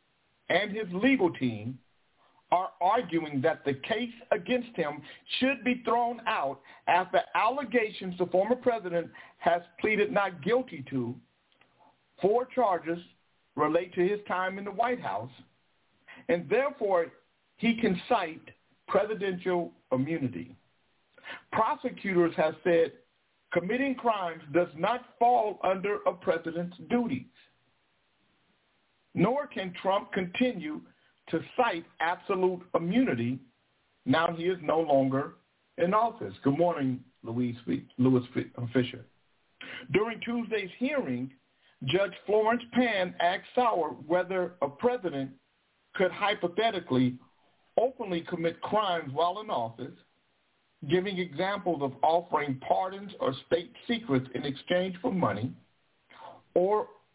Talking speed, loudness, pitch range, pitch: 110 wpm, -29 LUFS, 150-220 Hz, 180 Hz